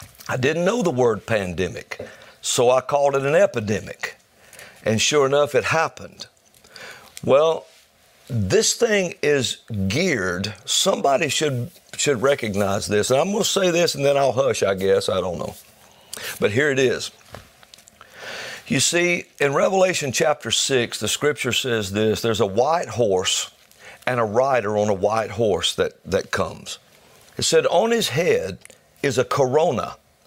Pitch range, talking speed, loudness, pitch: 110-175 Hz, 155 wpm, -20 LUFS, 140 Hz